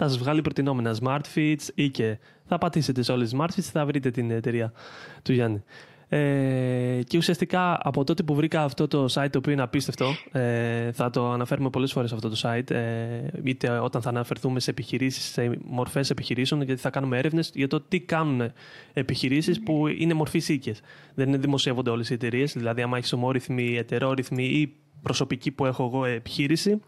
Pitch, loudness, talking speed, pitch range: 135 Hz, -26 LUFS, 185 wpm, 125-150 Hz